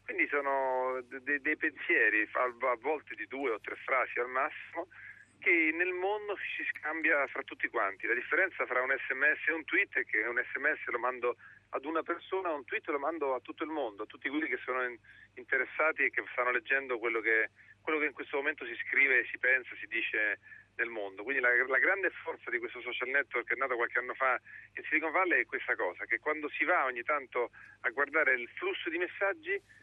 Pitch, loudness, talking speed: 160 Hz, -32 LUFS, 210 wpm